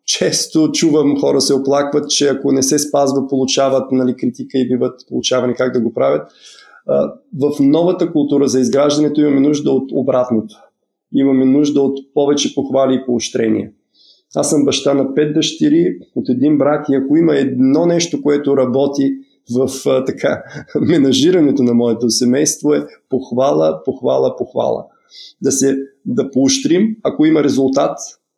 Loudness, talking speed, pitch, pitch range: -15 LUFS, 145 wpm, 140 Hz, 130-150 Hz